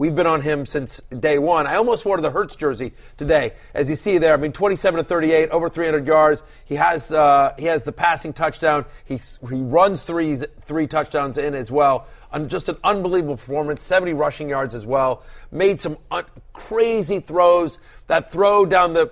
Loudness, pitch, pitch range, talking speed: -19 LUFS, 155 Hz, 145-175 Hz, 195 wpm